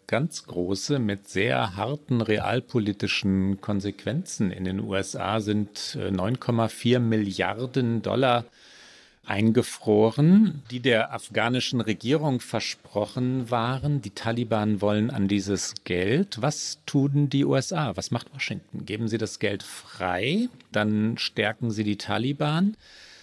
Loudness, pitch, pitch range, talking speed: -26 LUFS, 115 Hz, 105-130 Hz, 115 wpm